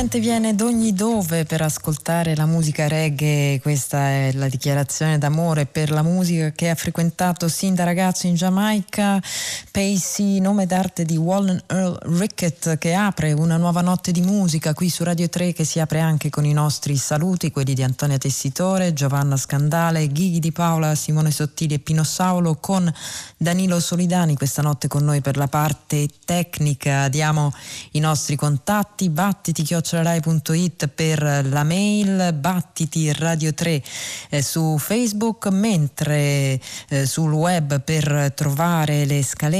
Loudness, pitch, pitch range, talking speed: -20 LUFS, 160 Hz, 150-180 Hz, 150 wpm